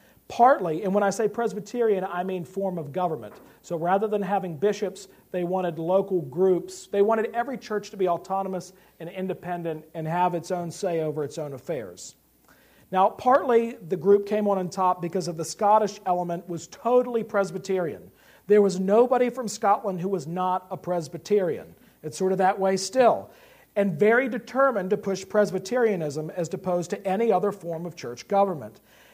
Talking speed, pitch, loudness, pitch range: 175 wpm, 190 Hz, -25 LUFS, 175-210 Hz